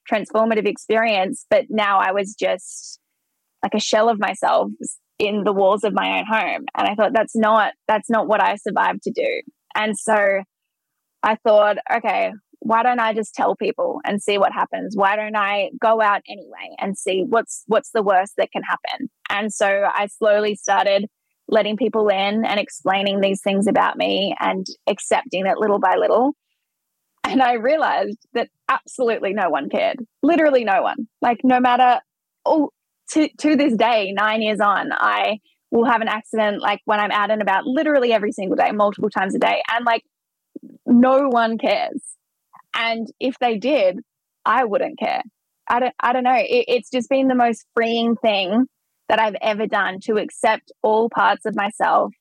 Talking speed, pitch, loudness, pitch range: 180 wpm, 225 Hz, -19 LUFS, 210-255 Hz